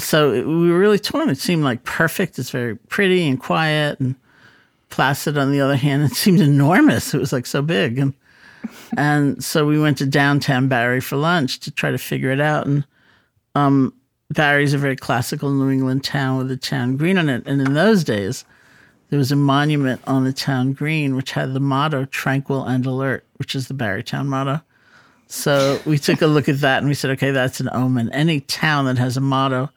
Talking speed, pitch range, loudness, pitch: 210 wpm, 130-150 Hz, -18 LUFS, 140 Hz